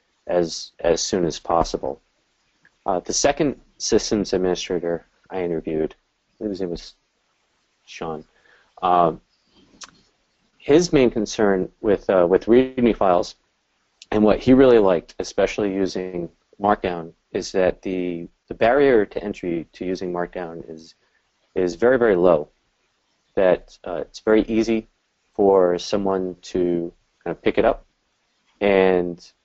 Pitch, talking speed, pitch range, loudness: 90 Hz, 125 wpm, 85-100 Hz, -21 LUFS